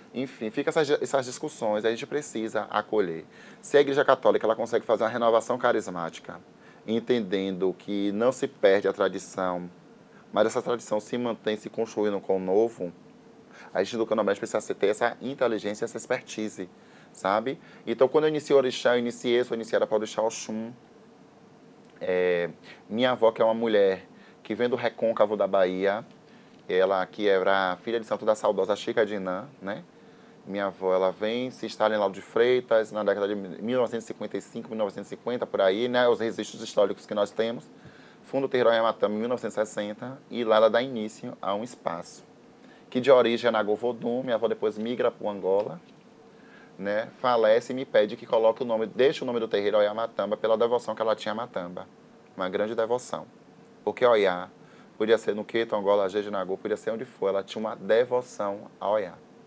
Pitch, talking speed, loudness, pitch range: 110 Hz, 180 wpm, -27 LUFS, 100-120 Hz